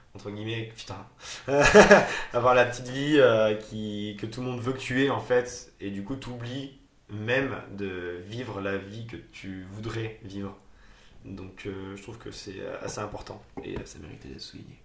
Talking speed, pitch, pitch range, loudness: 180 wpm, 110 Hz, 100-125 Hz, -25 LUFS